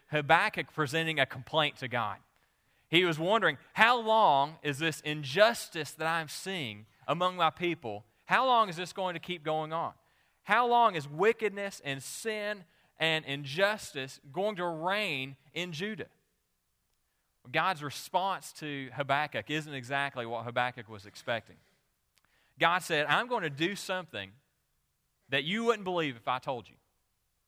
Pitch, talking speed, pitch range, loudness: 155 Hz, 145 wpm, 135-180 Hz, -31 LUFS